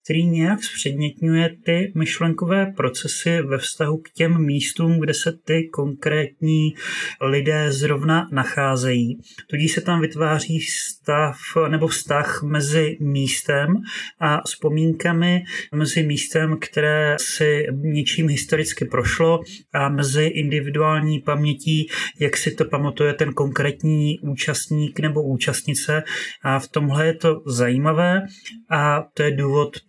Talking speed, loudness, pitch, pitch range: 120 wpm, -20 LUFS, 155 Hz, 145-160 Hz